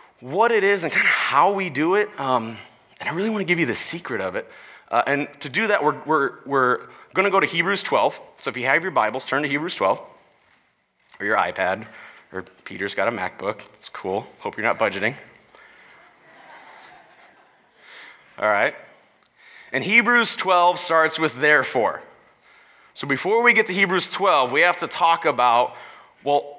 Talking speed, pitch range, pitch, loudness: 185 wpm, 145-200 Hz, 170 Hz, -21 LUFS